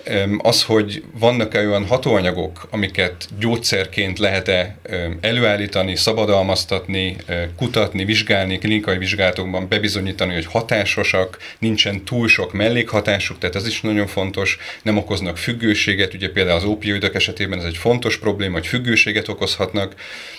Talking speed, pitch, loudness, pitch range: 120 wpm, 100 Hz, -18 LUFS, 95-110 Hz